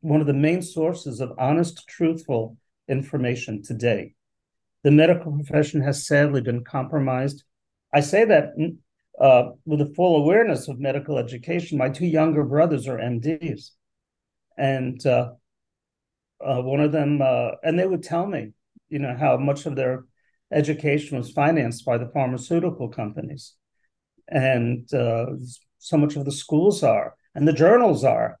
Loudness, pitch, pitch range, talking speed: -22 LUFS, 145 Hz, 130-155 Hz, 150 wpm